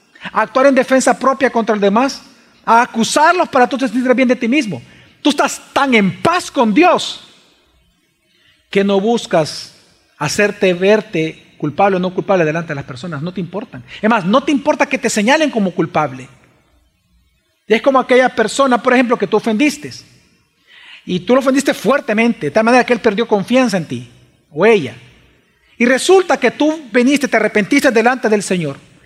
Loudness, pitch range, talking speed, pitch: -14 LUFS, 190-265 Hz, 180 wpm, 230 Hz